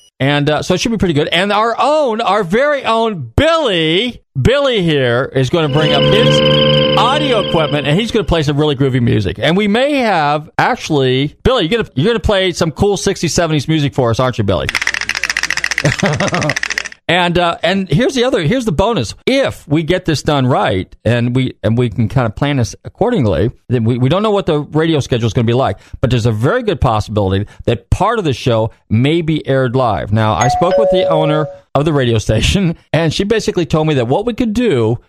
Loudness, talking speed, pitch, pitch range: -14 LUFS, 225 wpm, 145 Hz, 120-180 Hz